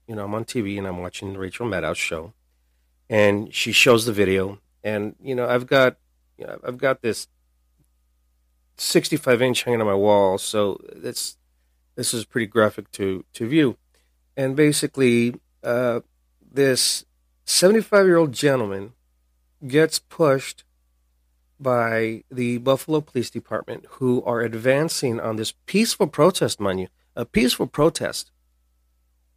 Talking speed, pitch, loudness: 140 wpm, 105 Hz, -21 LUFS